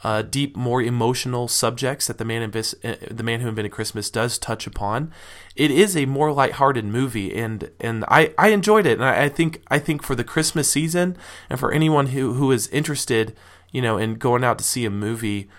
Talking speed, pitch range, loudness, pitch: 220 wpm, 110-145 Hz, -21 LUFS, 120 Hz